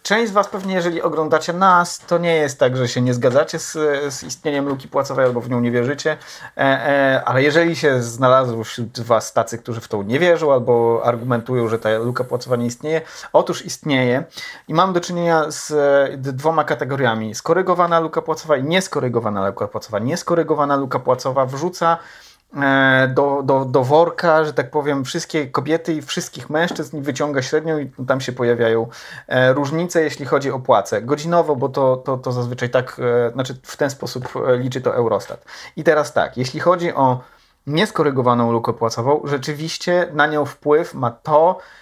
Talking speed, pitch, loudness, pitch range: 170 wpm, 140 Hz, -18 LUFS, 125-160 Hz